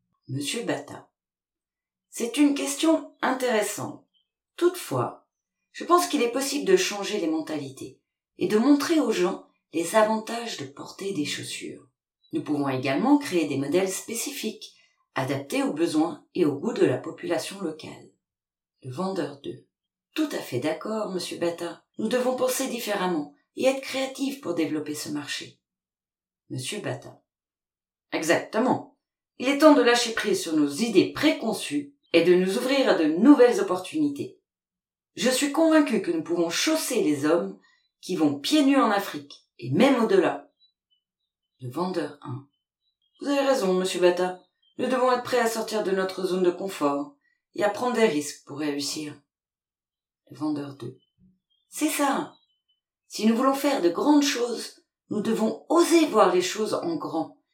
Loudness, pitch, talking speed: -25 LUFS, 220 Hz, 155 wpm